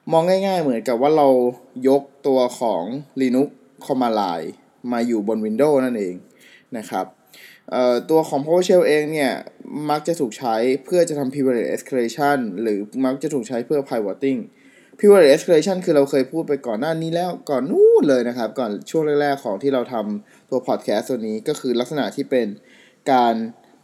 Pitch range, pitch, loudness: 125-155 Hz, 135 Hz, -20 LUFS